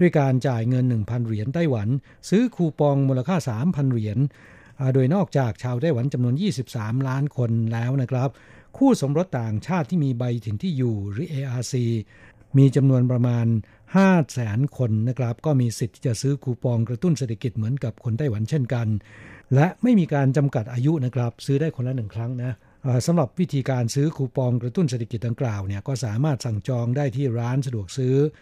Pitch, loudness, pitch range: 130 Hz, -23 LUFS, 115-140 Hz